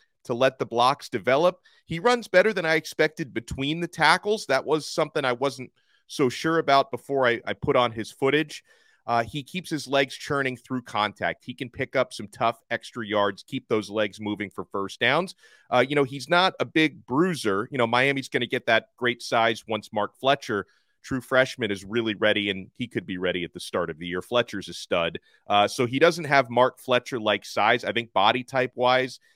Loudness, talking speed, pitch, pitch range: -25 LUFS, 215 wpm, 125 Hz, 115-145 Hz